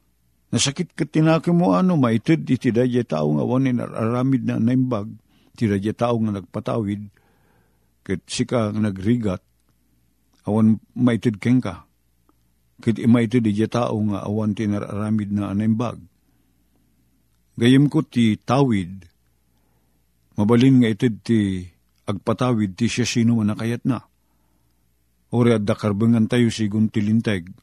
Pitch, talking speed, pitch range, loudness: 110 Hz, 125 wpm, 90-120 Hz, -21 LUFS